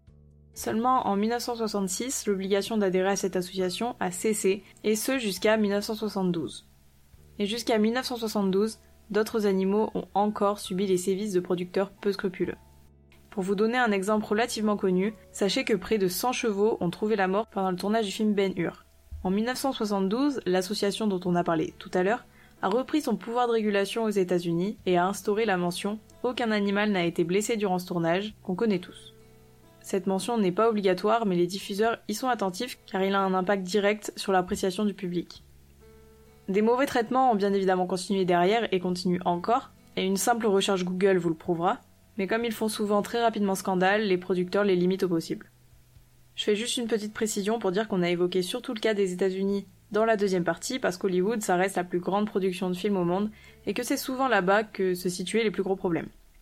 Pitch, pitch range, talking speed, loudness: 200 Hz, 180-220 Hz, 195 wpm, -27 LUFS